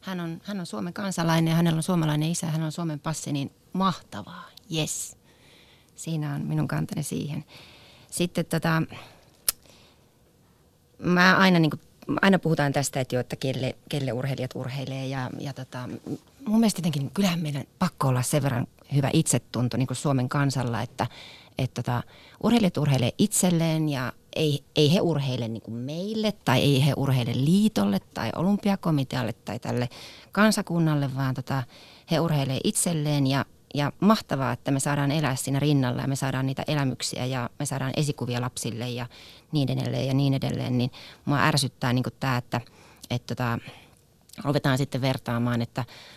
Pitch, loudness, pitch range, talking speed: 140 Hz, -26 LUFS, 125-160 Hz, 160 wpm